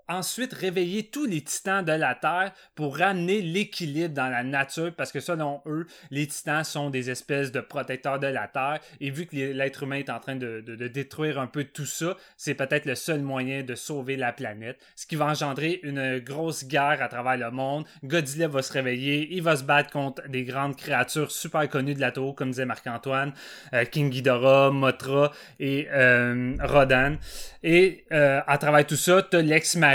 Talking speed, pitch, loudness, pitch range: 200 wpm, 140 Hz, -26 LUFS, 135-155 Hz